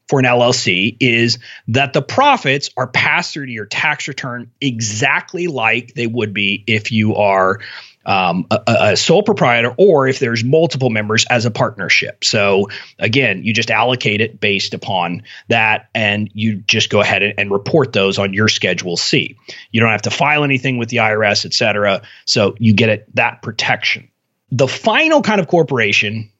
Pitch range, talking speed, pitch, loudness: 105-135 Hz, 180 wpm, 115 Hz, -14 LUFS